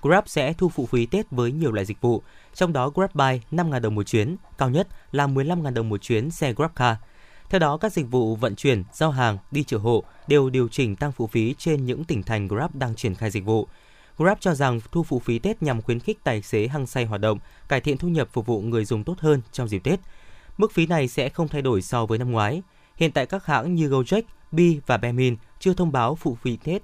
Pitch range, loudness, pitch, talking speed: 115-160 Hz, -24 LUFS, 135 Hz, 250 wpm